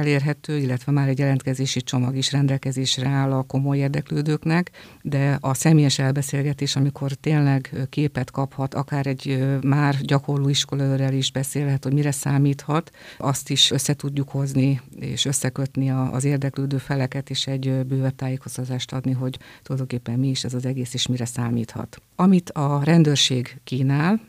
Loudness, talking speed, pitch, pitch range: -22 LUFS, 145 wpm, 135 Hz, 130-140 Hz